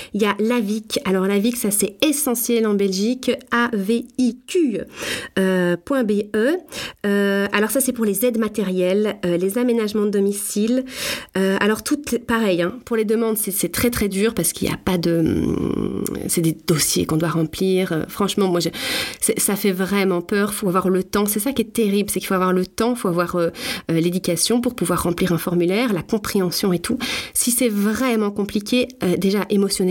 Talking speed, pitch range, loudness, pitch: 195 wpm, 185-235 Hz, -20 LUFS, 205 Hz